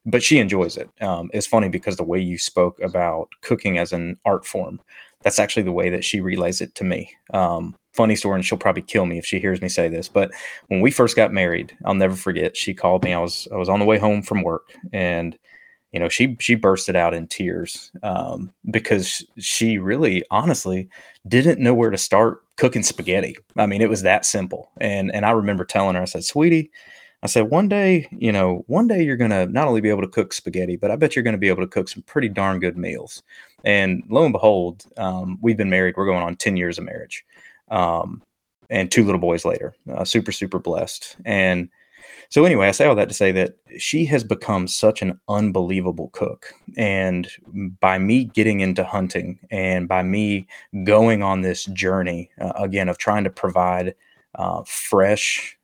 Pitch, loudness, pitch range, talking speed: 95 Hz, -20 LUFS, 90-110 Hz, 210 wpm